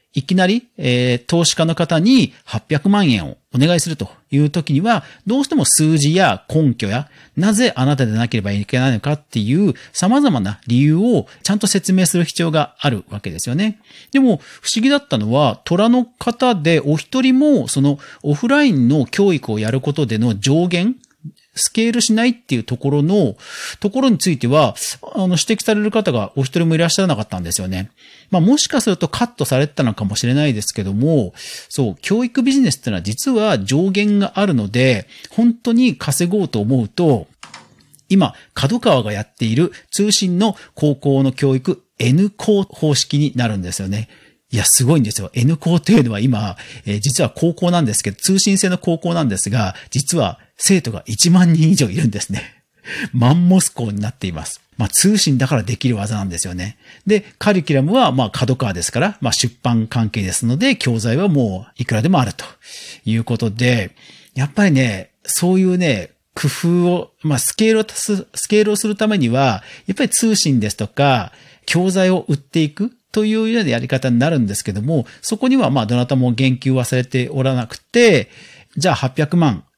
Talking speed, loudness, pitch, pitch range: 355 characters per minute, -16 LUFS, 150 Hz, 120-195 Hz